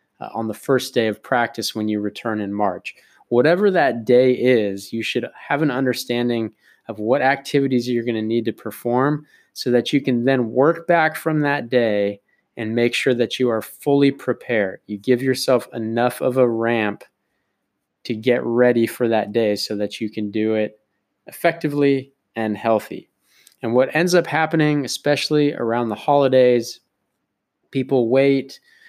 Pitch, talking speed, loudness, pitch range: 120 Hz, 170 wpm, -20 LUFS, 110-135 Hz